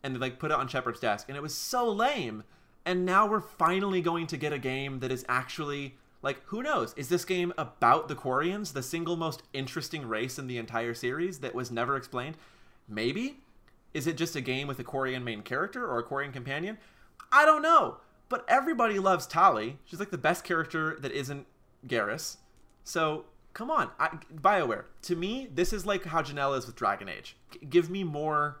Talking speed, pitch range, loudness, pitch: 205 wpm, 130-180 Hz, -30 LUFS, 150 Hz